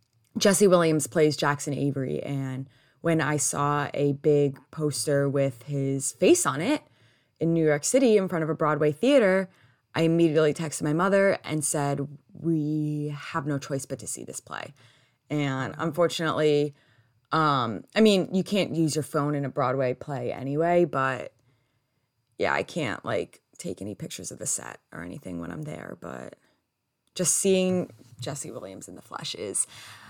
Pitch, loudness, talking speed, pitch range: 150 Hz, -26 LUFS, 165 wpm, 135-165 Hz